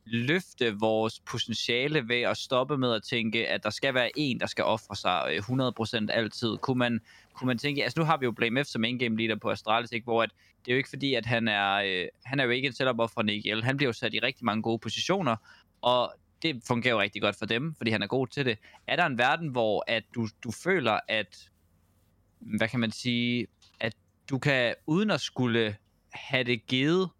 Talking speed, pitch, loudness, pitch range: 225 wpm, 115 Hz, -28 LUFS, 110-130 Hz